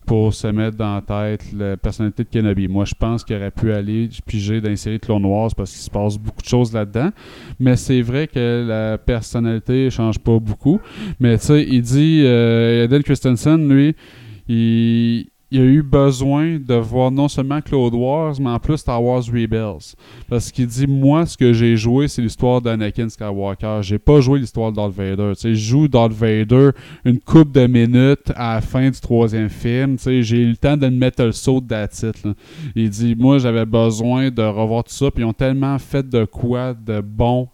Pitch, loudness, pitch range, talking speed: 120 Hz, -17 LUFS, 110-130 Hz, 205 wpm